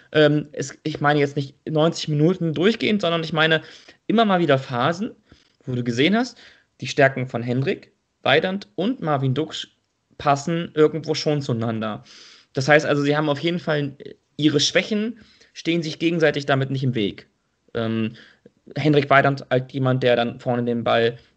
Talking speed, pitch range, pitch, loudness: 165 wpm, 130-160 Hz, 145 Hz, -21 LUFS